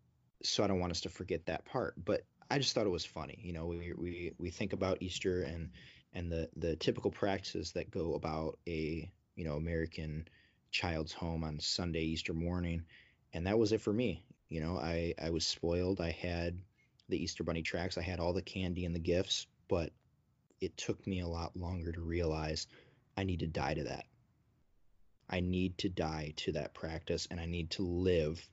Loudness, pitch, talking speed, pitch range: -38 LUFS, 85 Hz, 200 wpm, 80-90 Hz